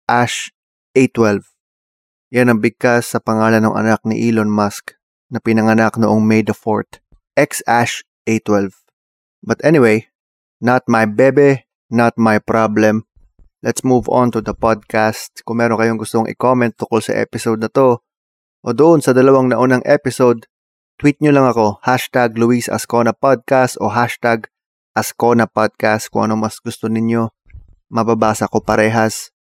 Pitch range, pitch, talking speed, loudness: 110-120 Hz, 115 Hz, 145 wpm, -15 LUFS